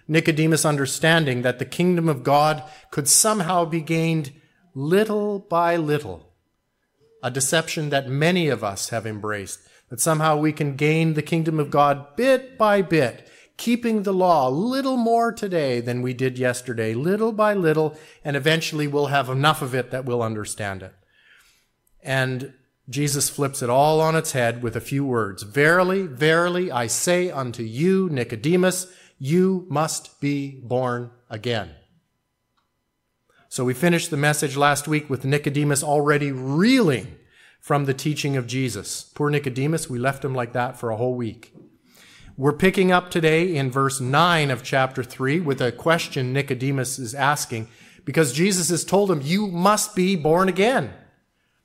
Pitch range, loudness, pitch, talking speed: 130-165 Hz, -21 LUFS, 145 Hz, 160 wpm